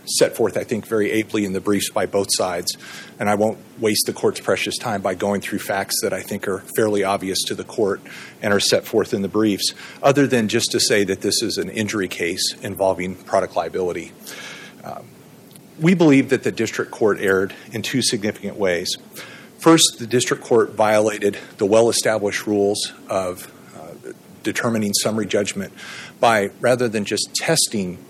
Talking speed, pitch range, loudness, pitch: 180 wpm, 100-120 Hz, -20 LUFS, 105 Hz